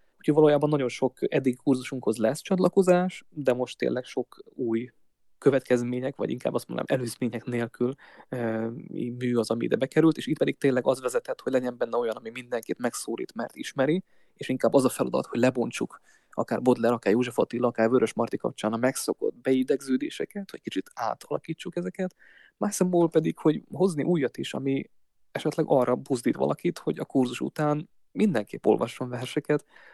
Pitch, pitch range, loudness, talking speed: 135 Hz, 125-175 Hz, -27 LUFS, 165 wpm